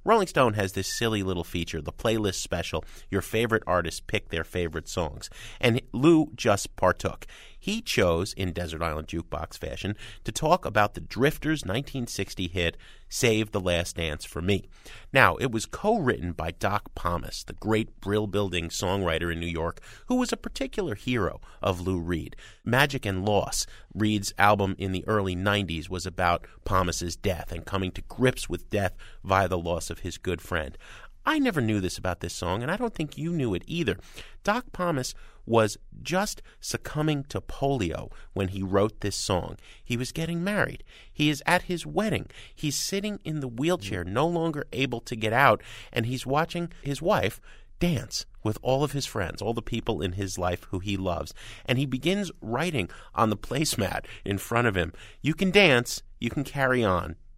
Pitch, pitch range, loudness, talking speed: 105 Hz, 90-135 Hz, -27 LUFS, 185 wpm